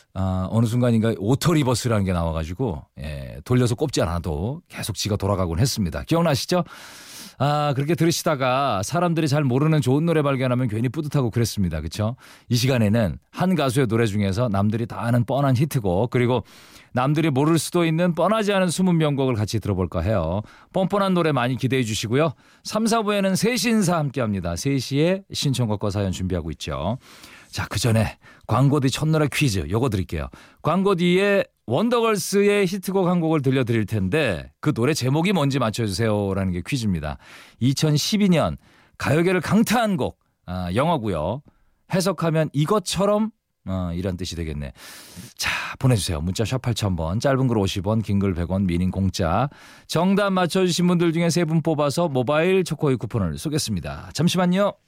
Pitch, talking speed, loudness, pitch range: 130 Hz, 355 characters per minute, -22 LUFS, 105-165 Hz